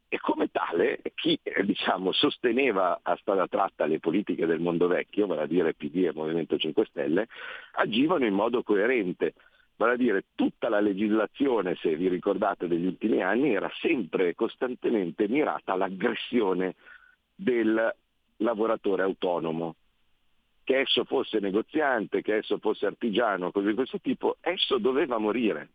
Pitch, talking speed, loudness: 270 Hz, 145 wpm, -27 LUFS